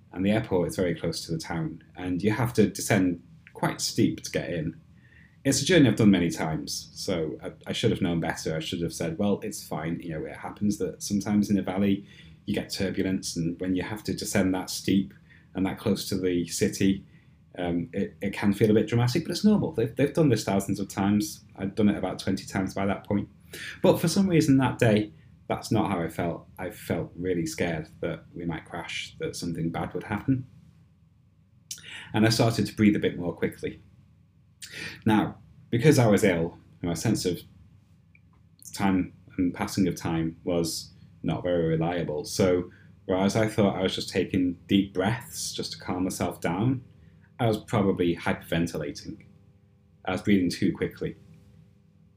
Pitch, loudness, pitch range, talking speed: 95 Hz, -27 LUFS, 90-110 Hz, 190 wpm